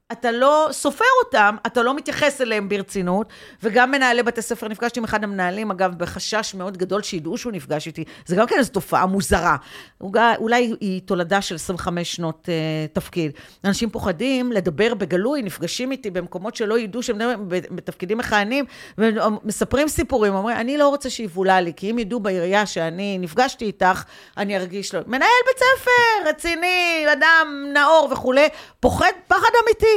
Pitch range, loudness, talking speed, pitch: 190-265 Hz, -20 LUFS, 160 wpm, 220 Hz